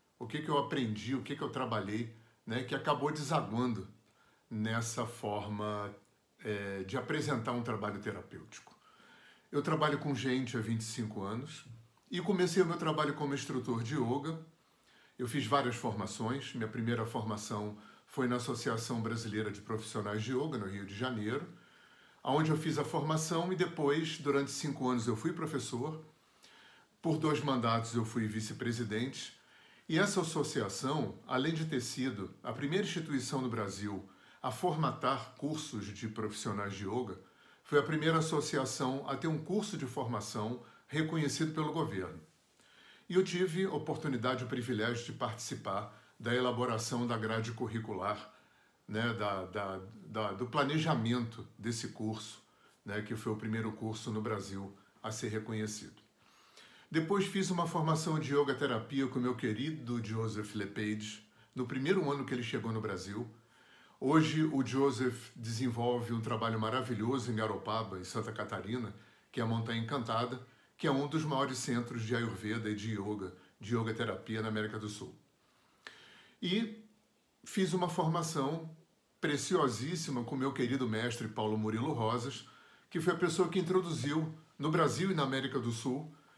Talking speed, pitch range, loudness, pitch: 155 wpm, 110-150 Hz, -36 LUFS, 125 Hz